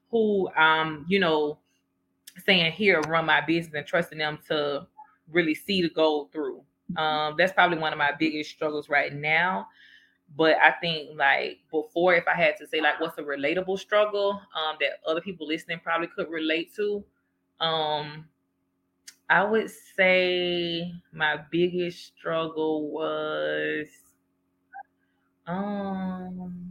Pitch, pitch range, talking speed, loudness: 160 Hz, 150-180 Hz, 140 wpm, -25 LUFS